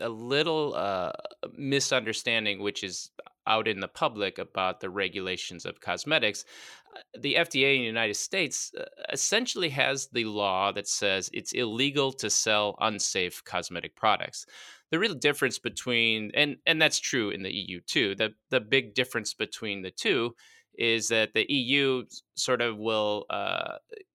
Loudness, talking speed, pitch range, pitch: -27 LUFS, 150 wpm, 110-140 Hz, 120 Hz